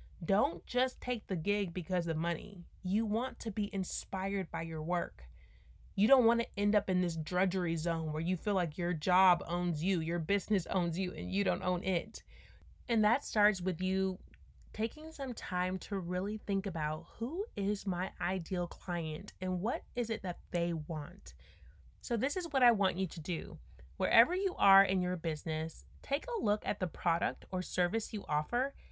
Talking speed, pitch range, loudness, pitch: 190 wpm, 170-210 Hz, -34 LUFS, 185 Hz